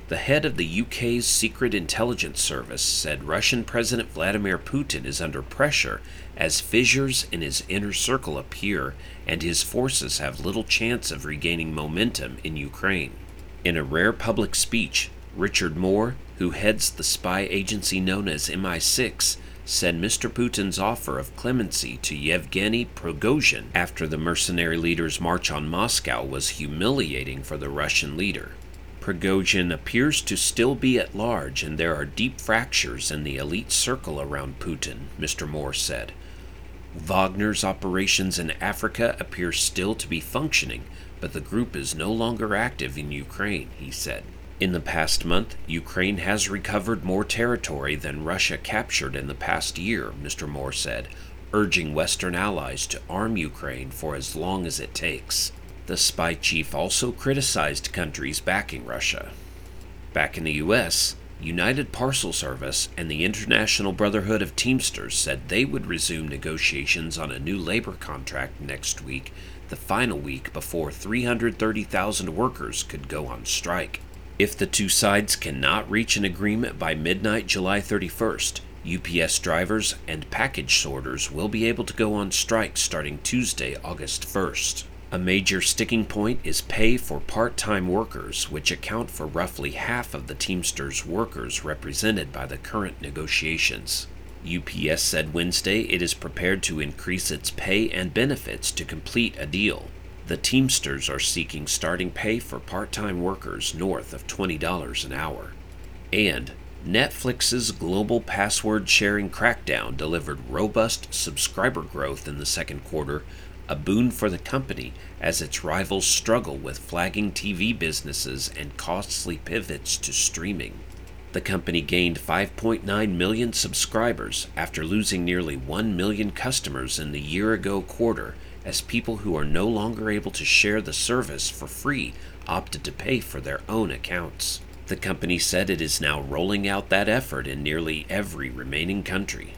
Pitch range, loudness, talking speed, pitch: 75-100 Hz, -25 LUFS, 150 wpm, 90 Hz